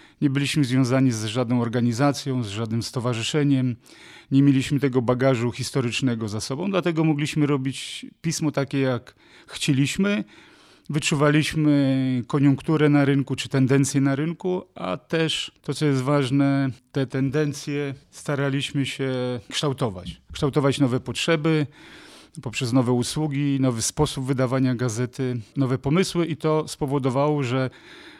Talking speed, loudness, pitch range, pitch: 125 wpm, -23 LUFS, 130-150 Hz, 140 Hz